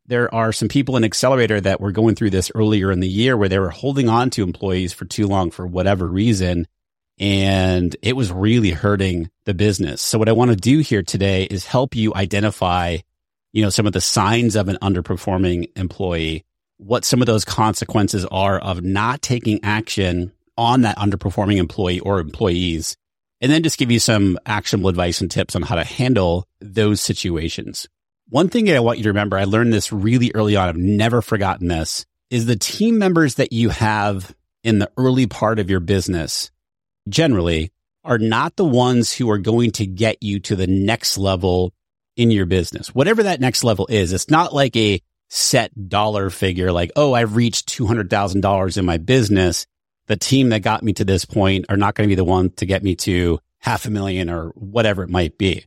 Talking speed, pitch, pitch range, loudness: 200 wpm, 100 Hz, 95-115 Hz, -18 LUFS